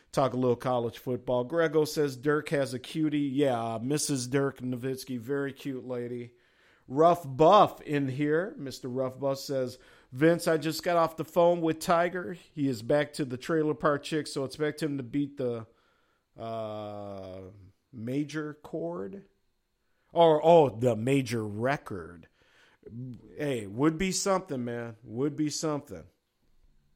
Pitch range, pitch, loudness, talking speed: 125-155 Hz, 140 Hz, -29 LUFS, 145 wpm